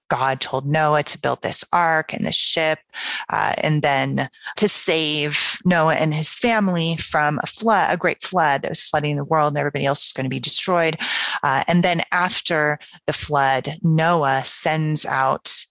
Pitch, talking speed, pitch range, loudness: 155 Hz, 180 wpm, 140-170 Hz, -19 LUFS